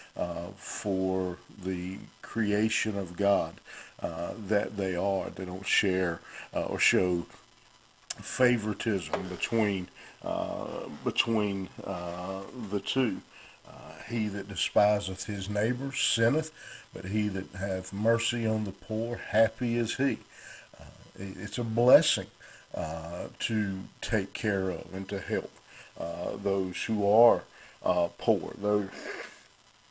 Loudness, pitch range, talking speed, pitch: -30 LUFS, 95-110 Hz, 120 wpm, 100 Hz